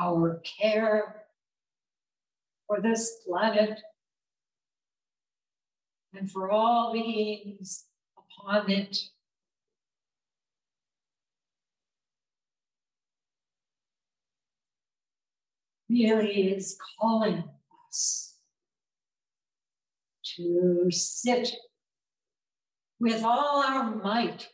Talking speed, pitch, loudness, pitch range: 50 wpm, 215 Hz, -27 LUFS, 195-230 Hz